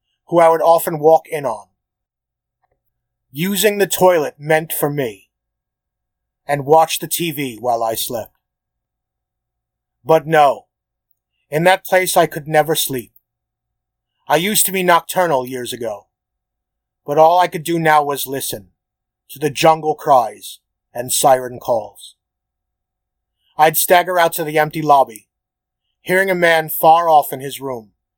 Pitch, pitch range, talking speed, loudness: 155 Hz, 130-170 Hz, 140 wpm, -15 LUFS